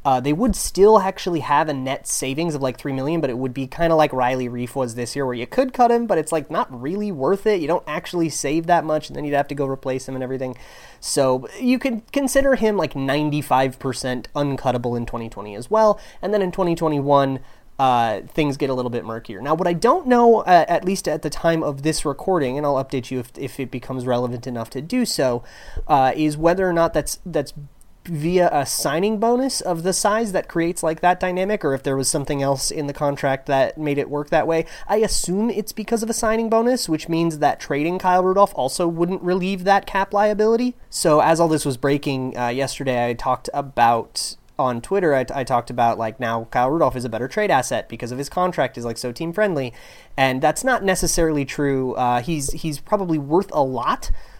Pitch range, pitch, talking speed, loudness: 130-185 Hz, 150 Hz, 225 wpm, -20 LUFS